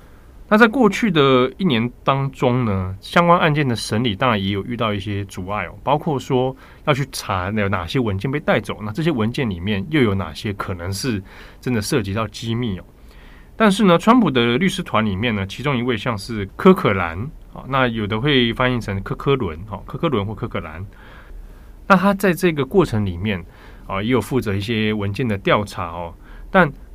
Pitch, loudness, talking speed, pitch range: 115 Hz, -19 LUFS, 285 characters per minute, 100-135 Hz